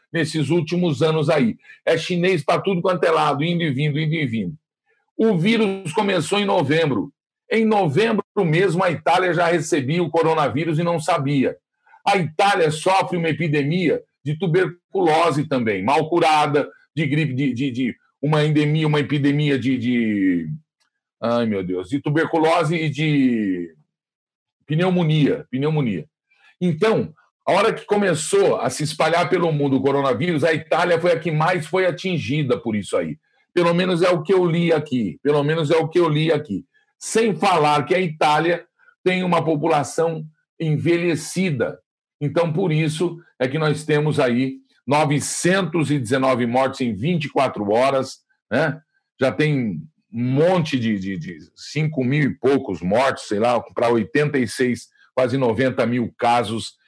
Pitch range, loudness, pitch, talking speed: 140-175 Hz, -20 LUFS, 155 Hz, 155 wpm